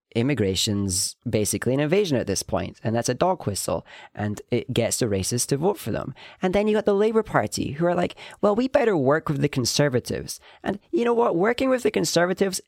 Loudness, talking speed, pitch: -23 LUFS, 220 wpm, 140 Hz